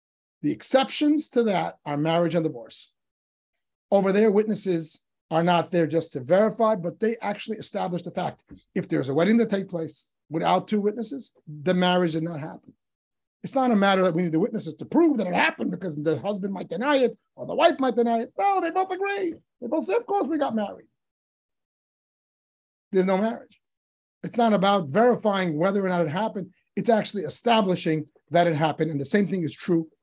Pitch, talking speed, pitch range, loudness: 200 Hz, 200 wpm, 170-230 Hz, -24 LUFS